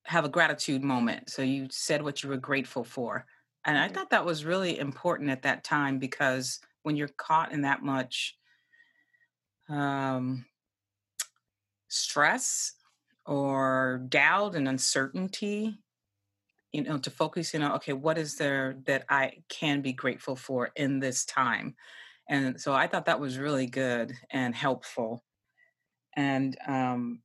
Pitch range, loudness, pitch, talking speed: 130-155 Hz, -29 LUFS, 135 Hz, 145 wpm